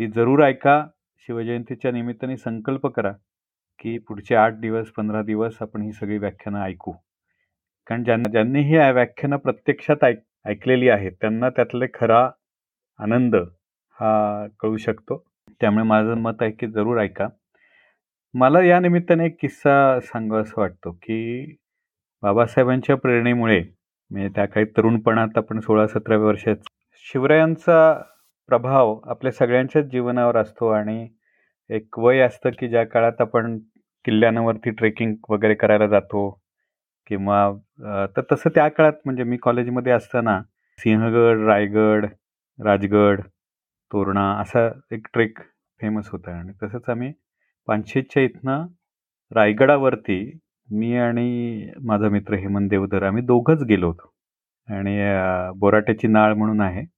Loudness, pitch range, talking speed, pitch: -20 LUFS, 105-125 Hz, 125 wpm, 115 Hz